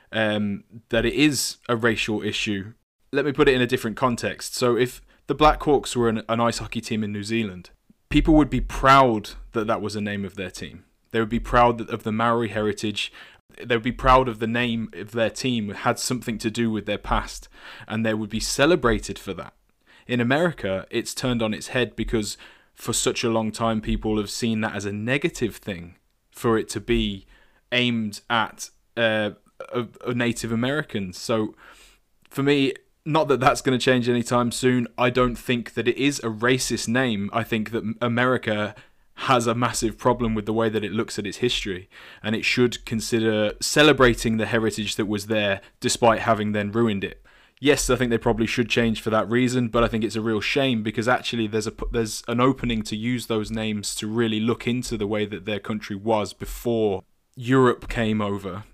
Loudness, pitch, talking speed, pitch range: -23 LUFS, 115 Hz, 205 wpm, 110-125 Hz